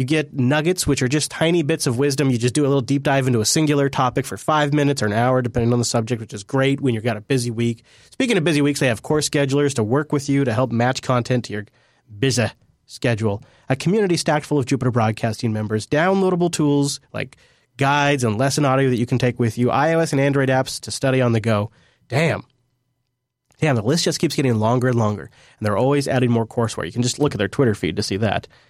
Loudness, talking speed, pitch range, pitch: -20 LUFS, 245 wpm, 120-145 Hz, 130 Hz